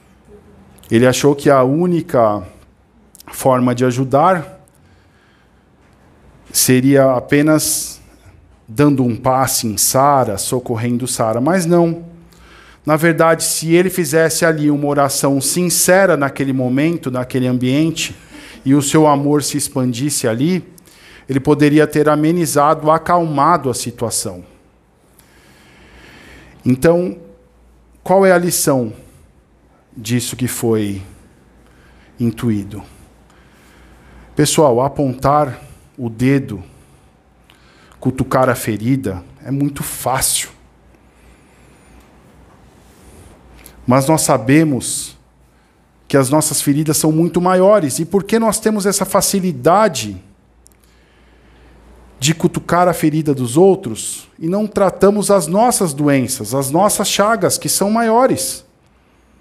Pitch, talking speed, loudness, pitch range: 140 Hz, 100 wpm, -15 LUFS, 110-165 Hz